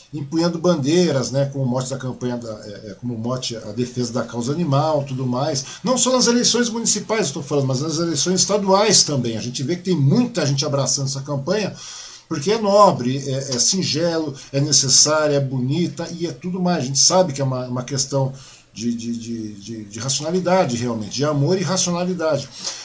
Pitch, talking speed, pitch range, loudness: 140 Hz, 190 wpm, 125-175 Hz, -19 LUFS